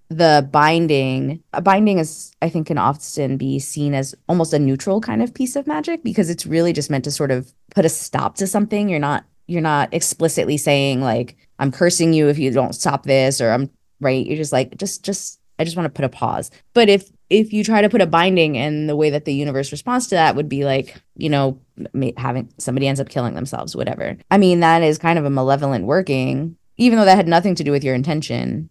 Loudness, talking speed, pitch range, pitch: -18 LUFS, 235 wpm, 135-175 Hz, 150 Hz